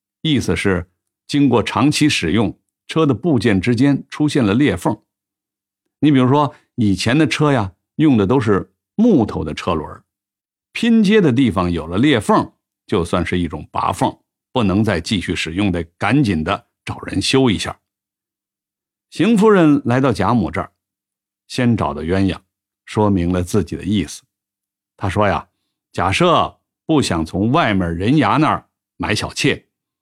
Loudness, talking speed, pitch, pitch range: -17 LUFS, 220 characters per minute, 100 Hz, 95-135 Hz